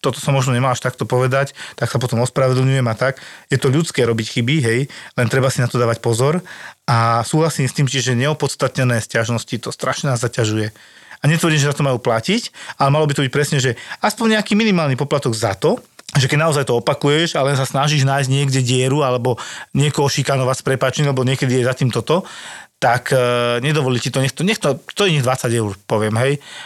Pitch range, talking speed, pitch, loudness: 125-145 Hz, 215 wpm, 135 Hz, -17 LUFS